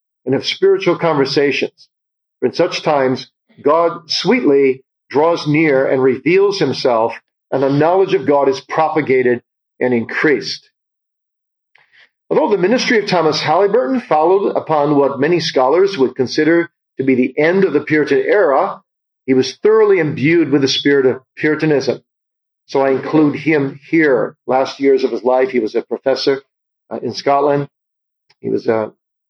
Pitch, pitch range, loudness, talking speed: 145 Hz, 135-170 Hz, -15 LUFS, 155 wpm